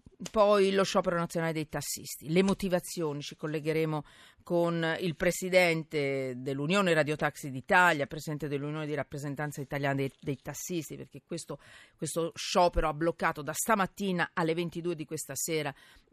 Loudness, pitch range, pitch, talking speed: -30 LUFS, 145-175 Hz, 160 Hz, 140 wpm